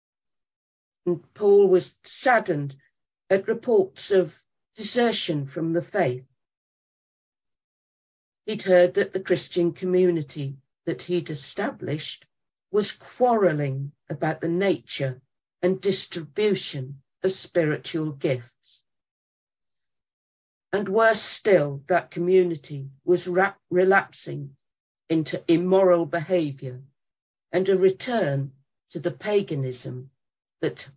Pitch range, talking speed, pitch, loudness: 135-190 Hz, 95 wpm, 170 Hz, -24 LUFS